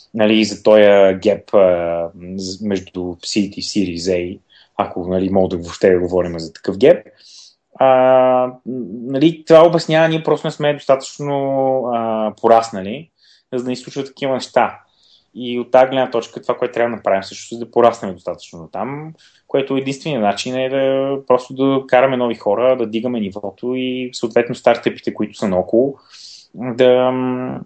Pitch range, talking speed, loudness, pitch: 100-130 Hz, 155 wpm, -16 LUFS, 120 Hz